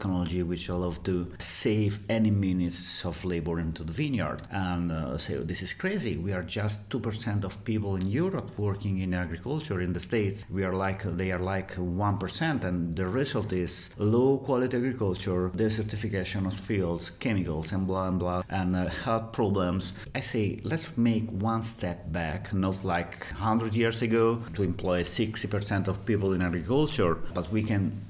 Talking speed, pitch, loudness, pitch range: 170 wpm, 95 Hz, -29 LUFS, 90-110 Hz